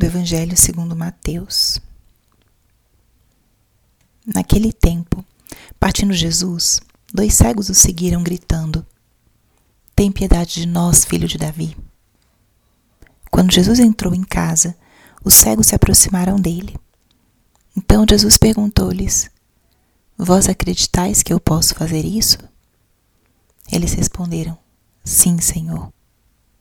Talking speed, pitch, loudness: 100 wpm, 165 Hz, -14 LUFS